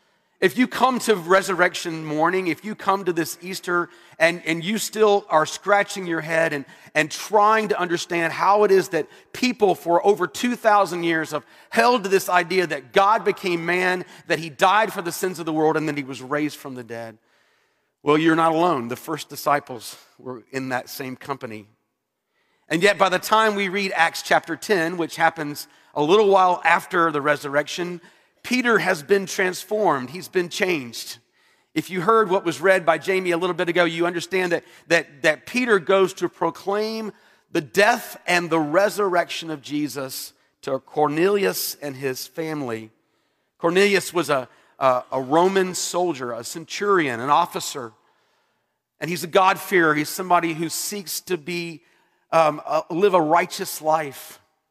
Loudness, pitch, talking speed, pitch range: -21 LUFS, 170 Hz, 170 wpm, 155-190 Hz